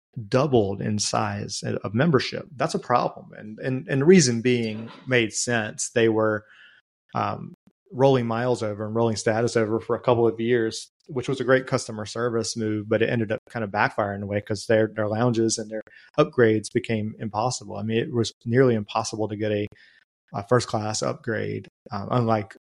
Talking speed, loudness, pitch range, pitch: 190 wpm, -24 LUFS, 110-125 Hz, 115 Hz